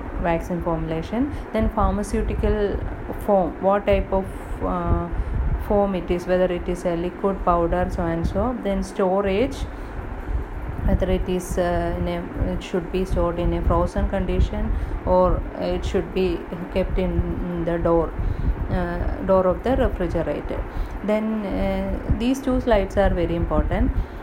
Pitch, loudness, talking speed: 180 Hz, -23 LUFS, 145 wpm